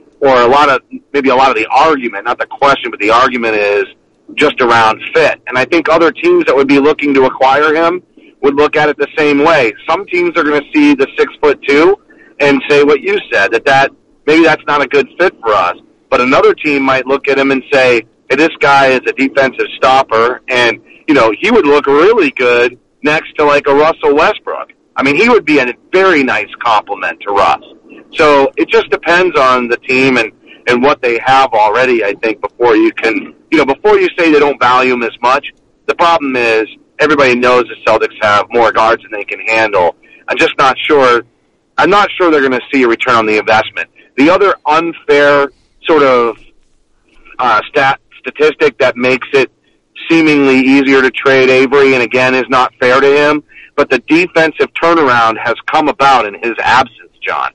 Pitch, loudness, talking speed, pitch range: 140 Hz, -10 LUFS, 205 wpm, 125-165 Hz